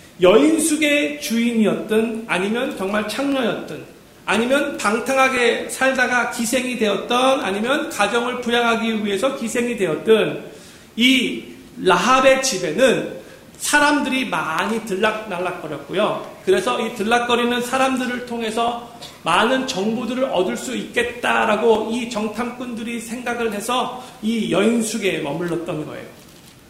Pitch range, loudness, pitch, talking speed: 215-255 Hz, -19 LUFS, 235 Hz, 285 characters per minute